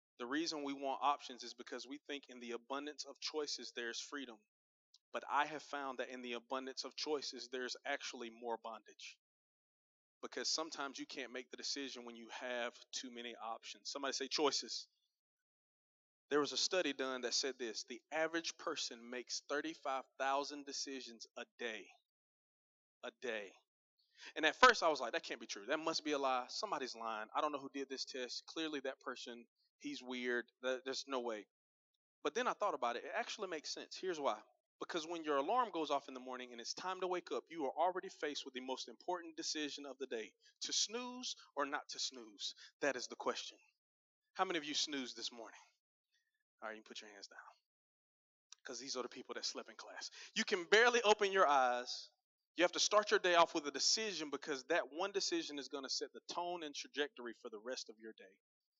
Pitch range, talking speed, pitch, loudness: 125-170 Hz, 205 wpm, 140 Hz, -40 LUFS